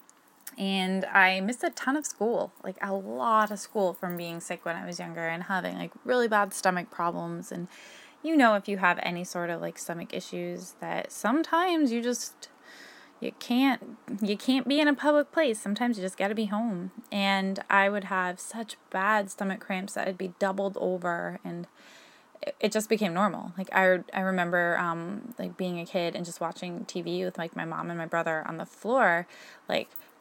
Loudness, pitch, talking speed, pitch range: -29 LUFS, 195 Hz, 195 wpm, 175-230 Hz